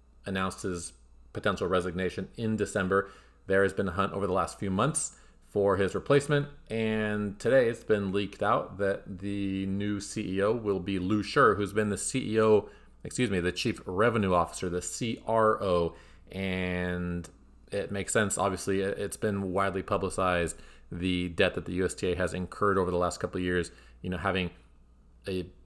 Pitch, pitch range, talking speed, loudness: 95 Hz, 90-105 Hz, 165 wpm, -29 LUFS